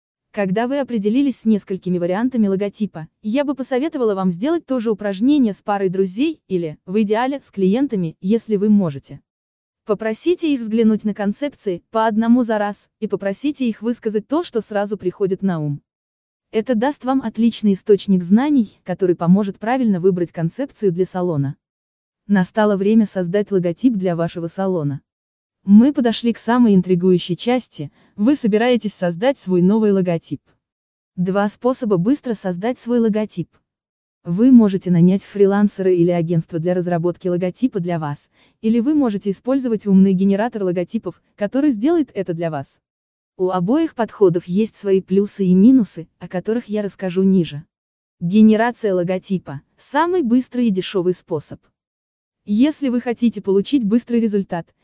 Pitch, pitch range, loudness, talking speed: 205 Hz, 180-235 Hz, -18 LUFS, 145 wpm